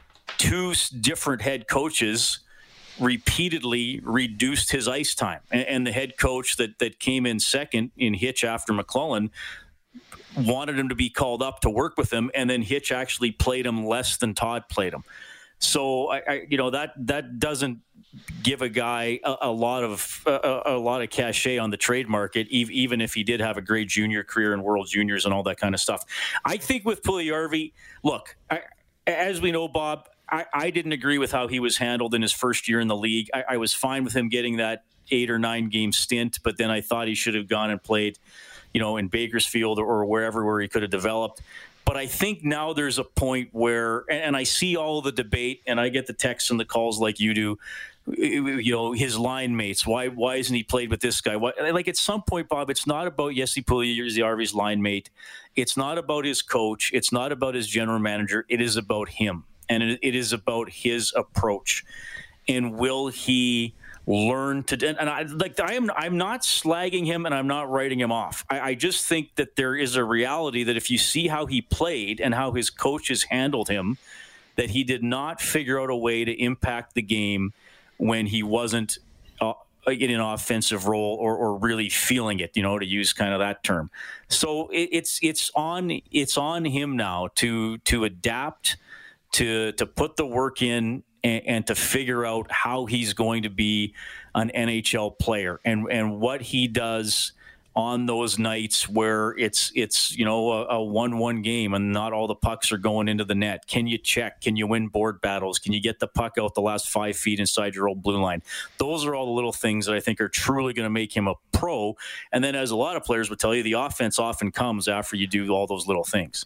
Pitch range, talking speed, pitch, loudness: 110-130 Hz, 215 wpm, 120 Hz, -25 LUFS